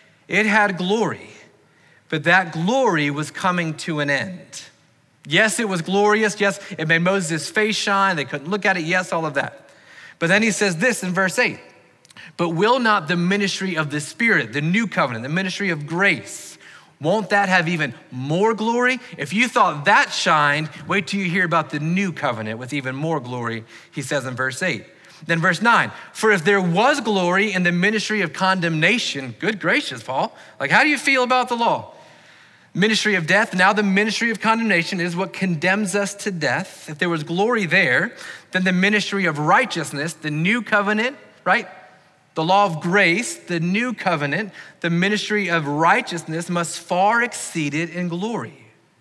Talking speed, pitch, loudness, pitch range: 185 wpm, 185 Hz, -19 LUFS, 160-205 Hz